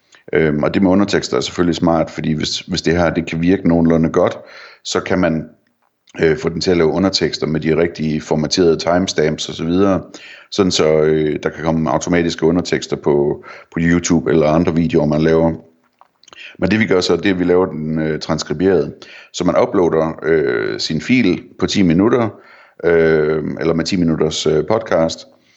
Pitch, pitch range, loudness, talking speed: 80 Hz, 80-85 Hz, -16 LUFS, 190 wpm